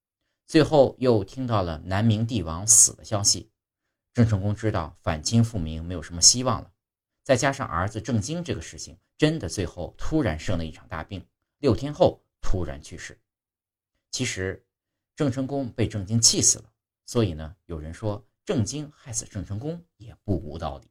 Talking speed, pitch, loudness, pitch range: 255 characters per minute, 110 Hz, -24 LUFS, 90-120 Hz